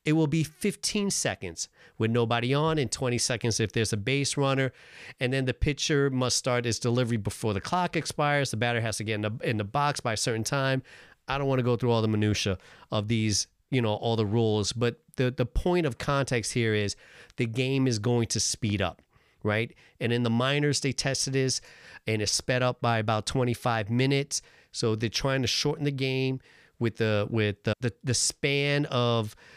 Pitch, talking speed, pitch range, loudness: 120 Hz, 210 wpm, 110-135 Hz, -27 LUFS